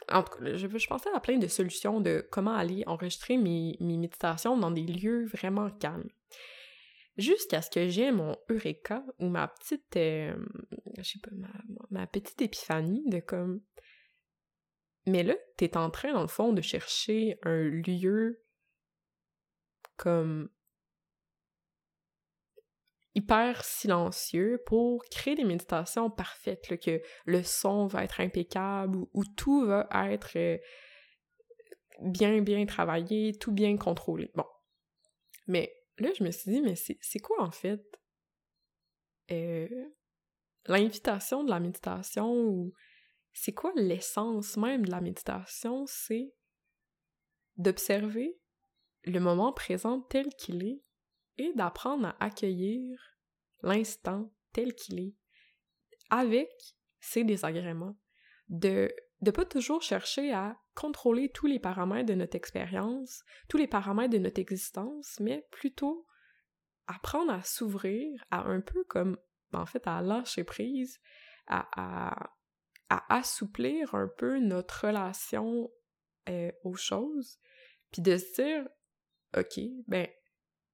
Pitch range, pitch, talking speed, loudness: 180-250 Hz, 210 Hz, 130 wpm, -32 LUFS